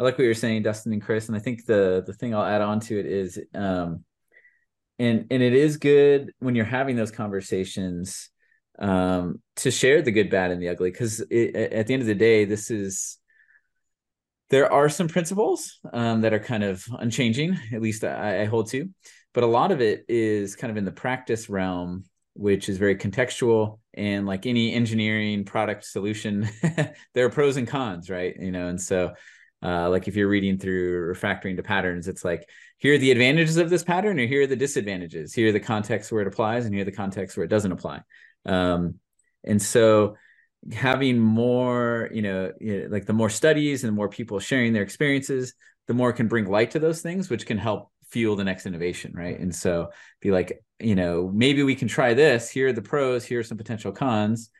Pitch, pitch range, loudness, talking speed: 110 Hz, 100-125 Hz, -24 LUFS, 210 wpm